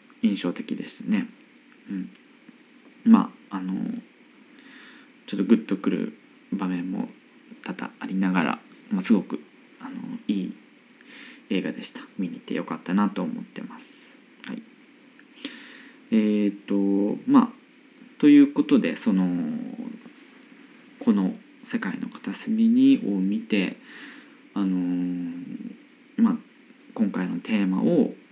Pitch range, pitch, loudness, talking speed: 230-275 Hz, 250 Hz, -25 LUFS, 210 characters per minute